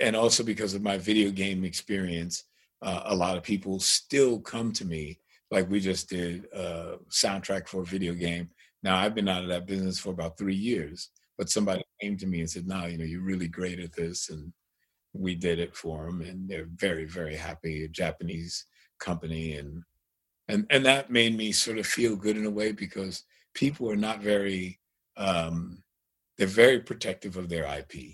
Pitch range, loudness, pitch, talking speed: 85-100 Hz, -29 LUFS, 95 Hz, 200 wpm